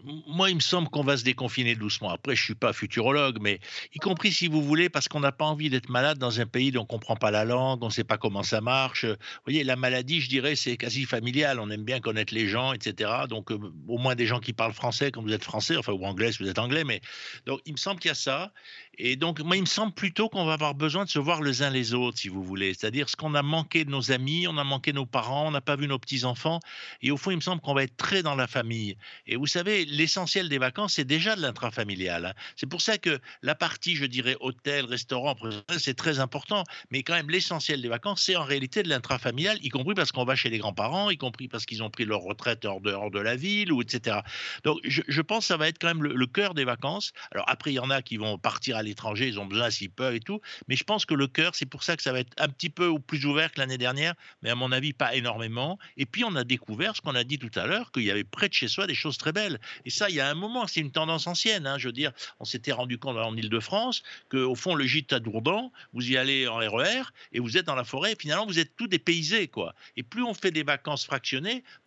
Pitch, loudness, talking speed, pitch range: 135 Hz, -27 LUFS, 280 wpm, 120-165 Hz